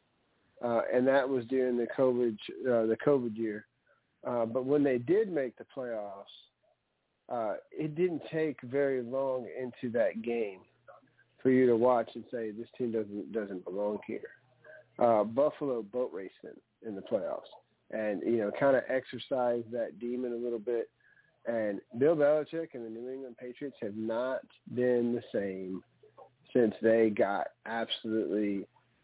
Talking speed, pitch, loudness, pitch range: 155 wpm, 120 Hz, -32 LUFS, 115-130 Hz